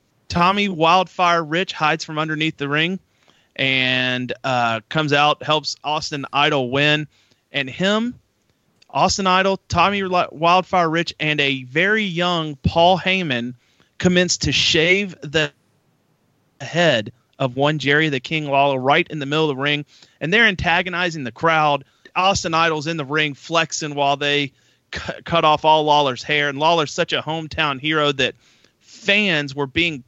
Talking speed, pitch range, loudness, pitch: 155 wpm, 145-170 Hz, -18 LUFS, 155 Hz